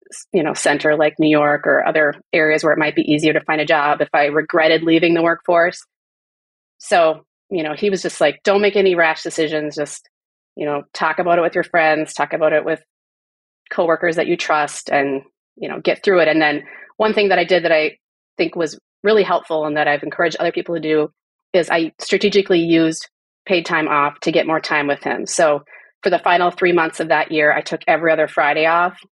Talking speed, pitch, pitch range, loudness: 220 wpm, 160 Hz, 155-175 Hz, -17 LUFS